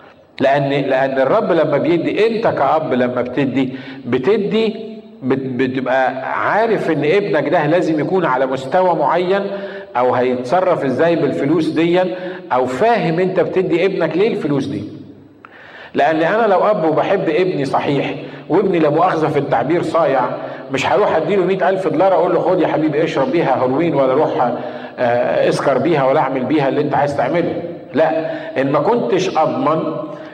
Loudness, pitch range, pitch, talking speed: -16 LUFS, 135-185 Hz, 160 Hz, 150 wpm